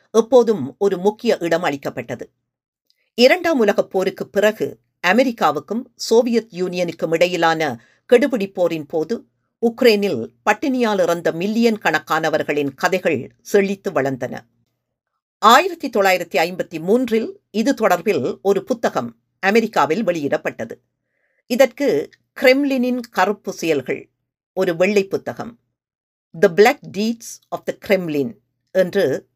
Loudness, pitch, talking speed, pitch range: -18 LUFS, 200 Hz, 100 wpm, 170-235 Hz